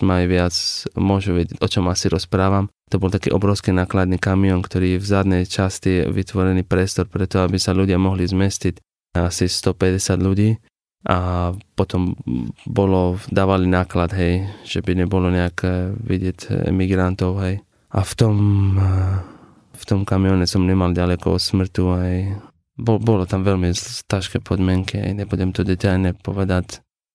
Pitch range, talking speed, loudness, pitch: 90-100 Hz, 145 wpm, -19 LUFS, 95 Hz